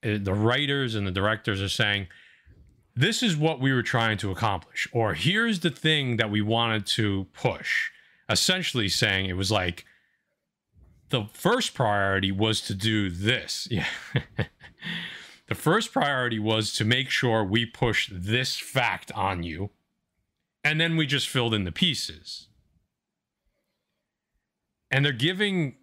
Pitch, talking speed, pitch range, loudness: 115 Hz, 140 wpm, 100-140 Hz, -25 LUFS